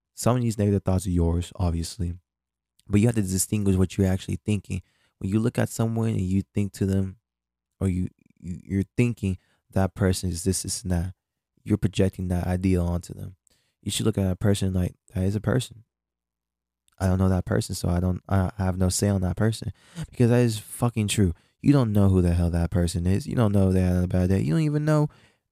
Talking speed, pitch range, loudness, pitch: 225 wpm, 90-110 Hz, -25 LUFS, 95 Hz